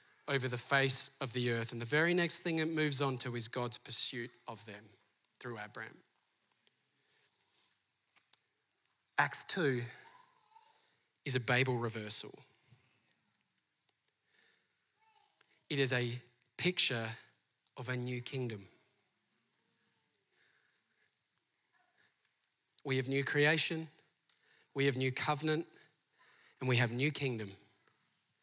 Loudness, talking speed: -35 LUFS, 105 wpm